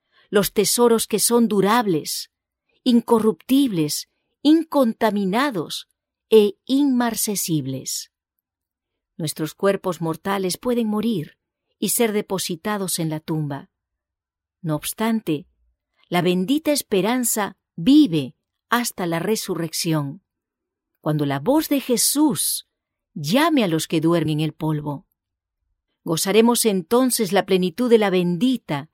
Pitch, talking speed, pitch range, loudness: 195 Hz, 100 wpm, 155-235 Hz, -20 LUFS